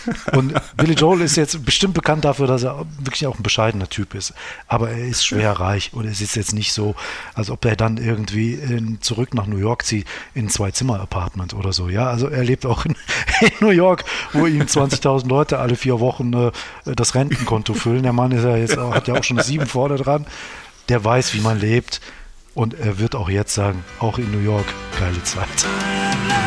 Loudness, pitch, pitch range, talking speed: -19 LUFS, 120 Hz, 105-135 Hz, 215 wpm